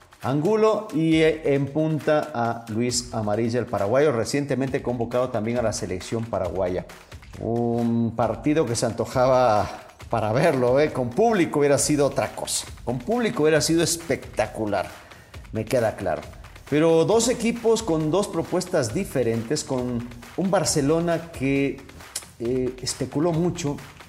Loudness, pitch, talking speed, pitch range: -23 LUFS, 130 Hz, 130 wpm, 115-160 Hz